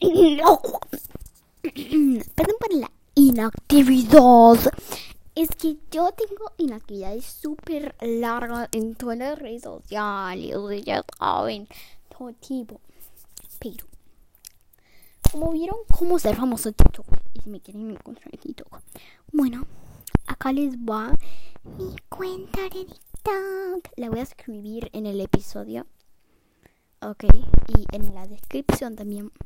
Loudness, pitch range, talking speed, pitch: -21 LUFS, 210-310 Hz, 115 wpm, 245 Hz